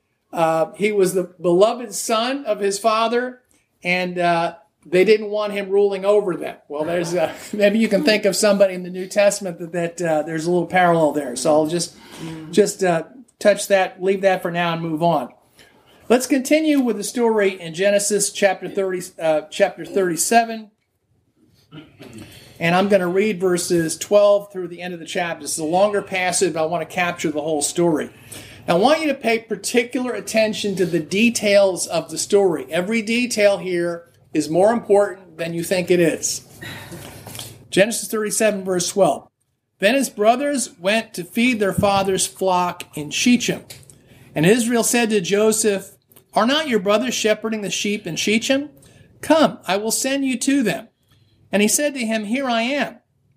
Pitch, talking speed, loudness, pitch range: 195 Hz, 180 wpm, -19 LUFS, 170-215 Hz